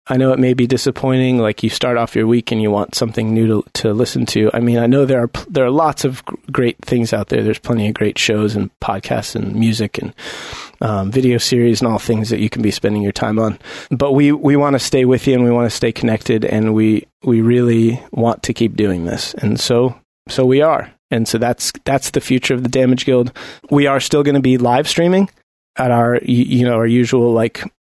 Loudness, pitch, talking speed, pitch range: -15 LUFS, 120 Hz, 245 wpm, 110-130 Hz